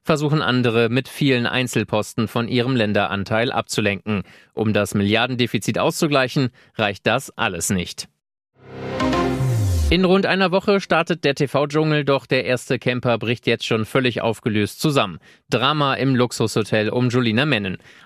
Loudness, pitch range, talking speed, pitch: -20 LUFS, 110-135 Hz, 135 wpm, 125 Hz